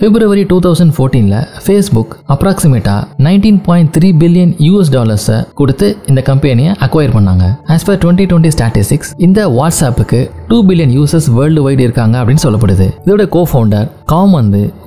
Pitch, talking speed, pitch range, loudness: 145 Hz, 145 wpm, 120-175 Hz, -9 LUFS